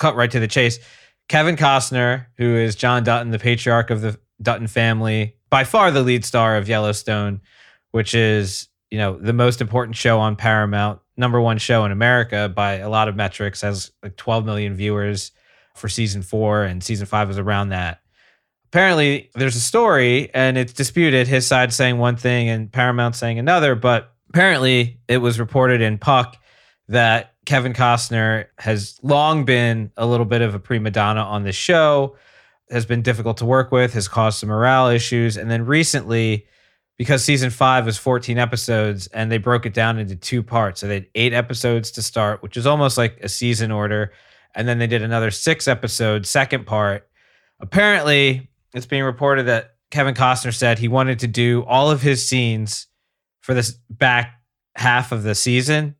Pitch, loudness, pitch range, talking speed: 120 Hz, -18 LUFS, 110-125 Hz, 185 wpm